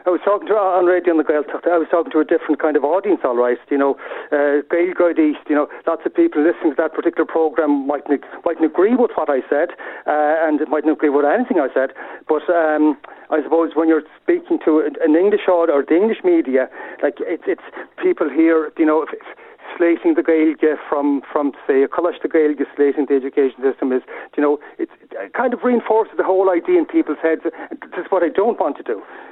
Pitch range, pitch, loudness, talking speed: 150-180 Hz, 160 Hz, -18 LUFS, 225 wpm